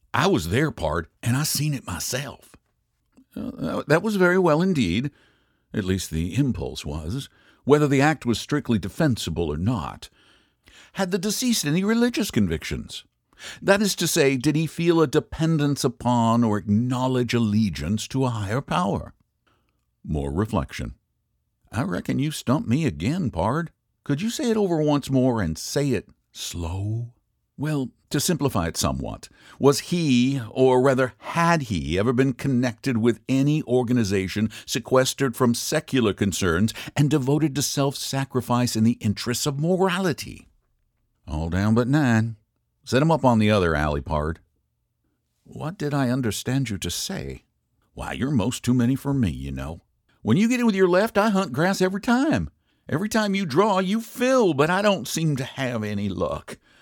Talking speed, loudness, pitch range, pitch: 165 wpm, -23 LUFS, 105-155 Hz, 130 Hz